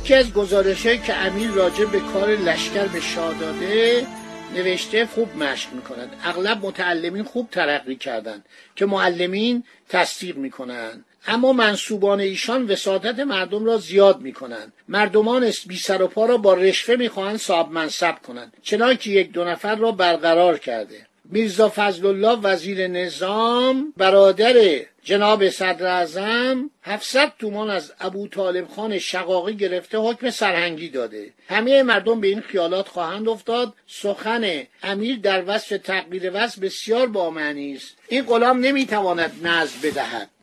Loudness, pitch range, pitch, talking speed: -20 LUFS, 180-225 Hz, 200 Hz, 140 wpm